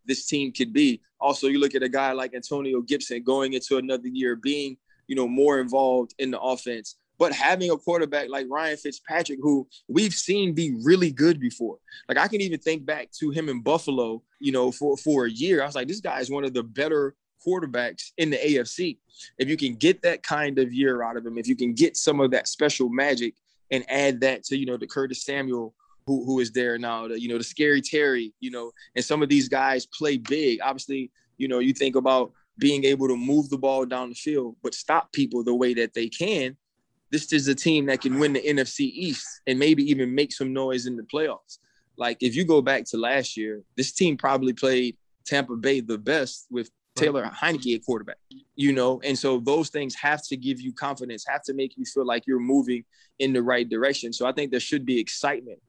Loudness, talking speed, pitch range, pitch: -25 LUFS, 225 wpm, 125-150 Hz, 135 Hz